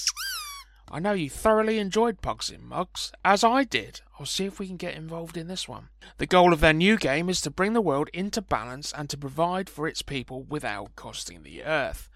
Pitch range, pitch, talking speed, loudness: 150-215 Hz, 180 Hz, 215 wpm, -26 LUFS